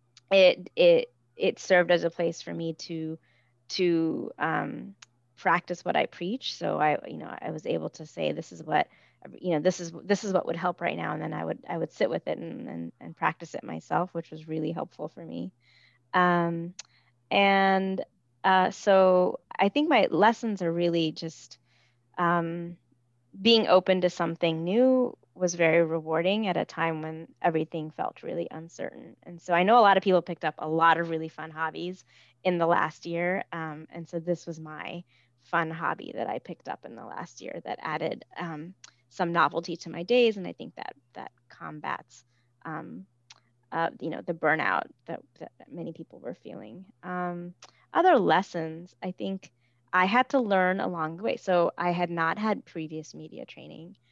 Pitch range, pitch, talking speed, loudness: 155-185 Hz, 170 Hz, 190 wpm, -27 LUFS